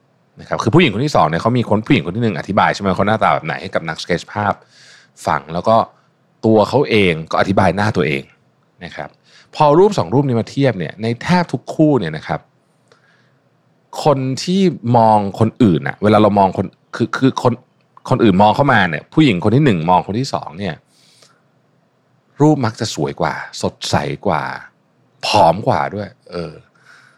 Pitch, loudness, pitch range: 115 Hz, -16 LUFS, 105-135 Hz